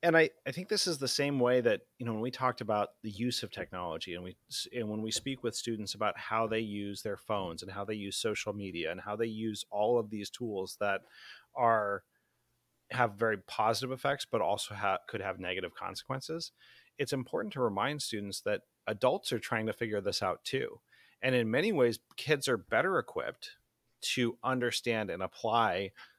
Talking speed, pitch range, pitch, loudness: 200 wpm, 105-130 Hz, 115 Hz, -33 LUFS